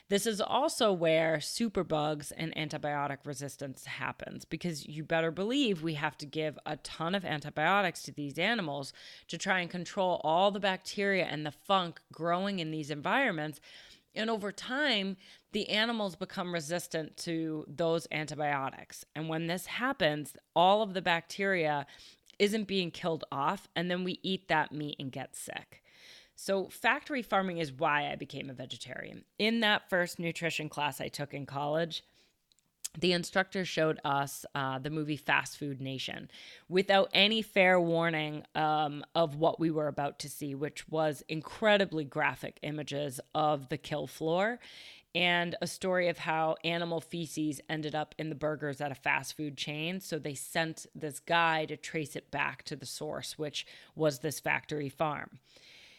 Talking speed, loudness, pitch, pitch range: 165 wpm, -32 LUFS, 160 Hz, 150-185 Hz